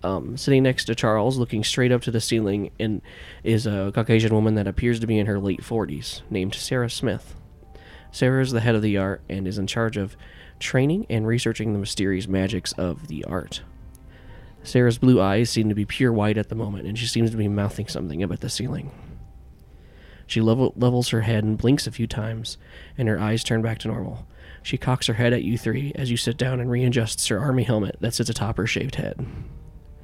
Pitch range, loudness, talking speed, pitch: 100-120 Hz, -23 LUFS, 215 wpm, 110 Hz